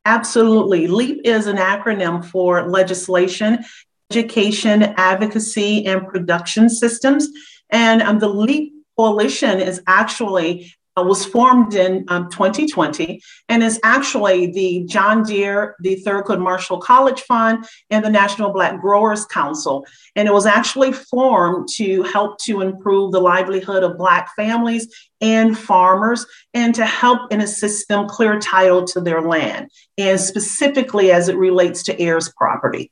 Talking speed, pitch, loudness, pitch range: 140 wpm, 205 Hz, -16 LUFS, 185-225 Hz